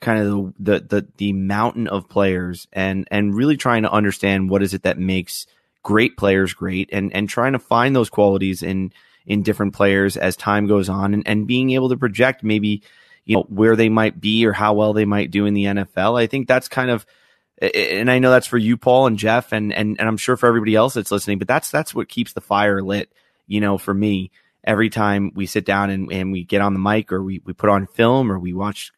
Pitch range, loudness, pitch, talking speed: 100-115 Hz, -18 LUFS, 105 Hz, 240 wpm